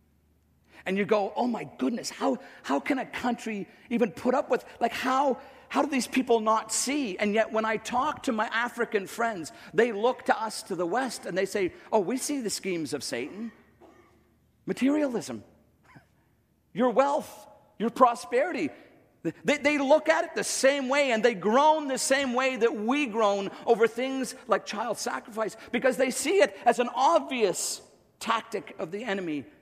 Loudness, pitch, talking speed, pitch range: -27 LUFS, 235 Hz, 175 wpm, 205-265 Hz